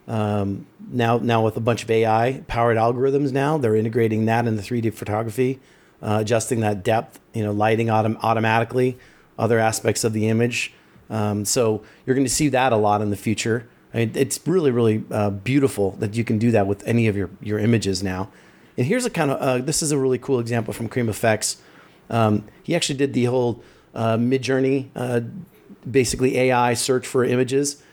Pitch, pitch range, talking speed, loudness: 115 Hz, 110-130 Hz, 195 wpm, -21 LUFS